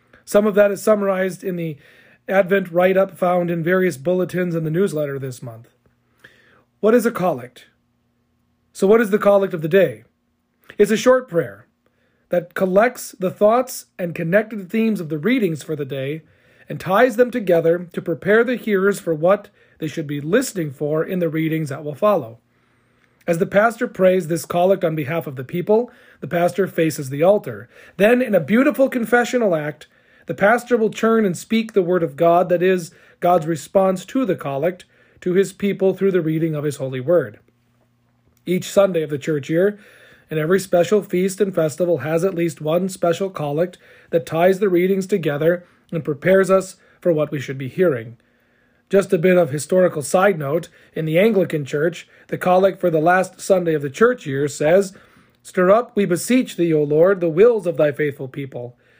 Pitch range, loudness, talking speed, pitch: 155-195 Hz, -19 LUFS, 190 wpm, 175 Hz